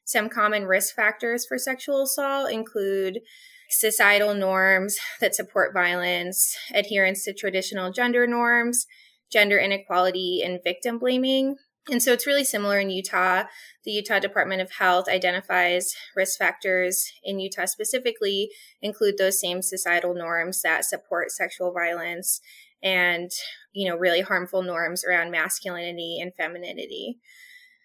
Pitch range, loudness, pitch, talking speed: 180-240 Hz, -23 LUFS, 195 Hz, 130 wpm